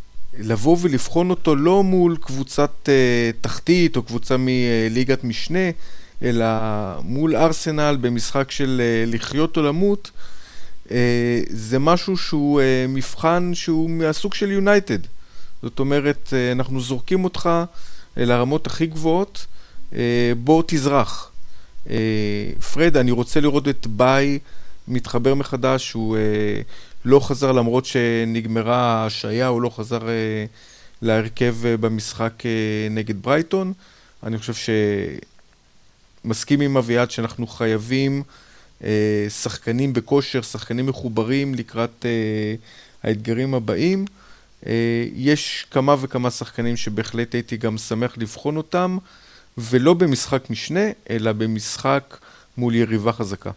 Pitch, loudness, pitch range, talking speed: 125 Hz, -21 LUFS, 115-145 Hz, 120 wpm